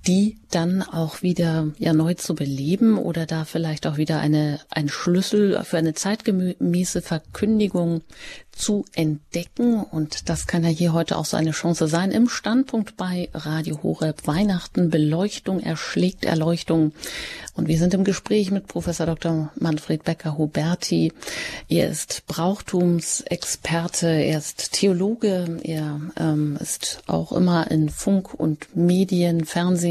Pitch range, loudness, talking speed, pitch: 160-185 Hz, -22 LUFS, 140 wpm, 170 Hz